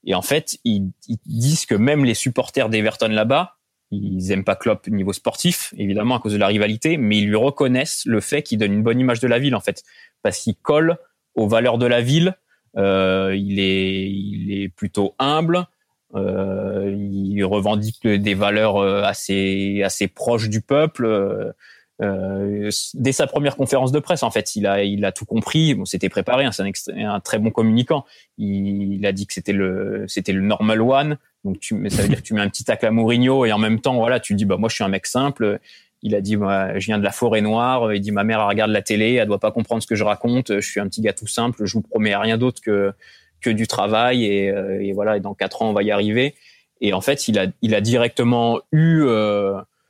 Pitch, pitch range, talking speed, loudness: 110 Hz, 100-120 Hz, 230 wpm, -20 LUFS